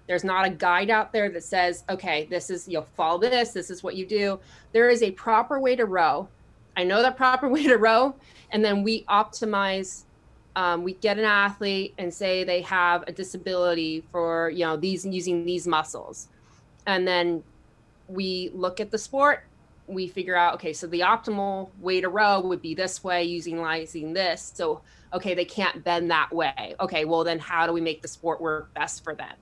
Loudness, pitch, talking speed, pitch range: -25 LUFS, 185 Hz, 205 wpm, 175-205 Hz